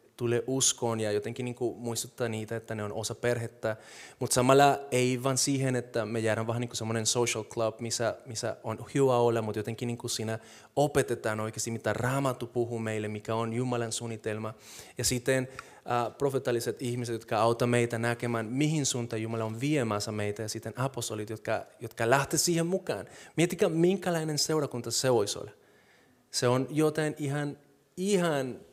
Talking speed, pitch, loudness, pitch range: 165 wpm, 120 Hz, -30 LUFS, 110-135 Hz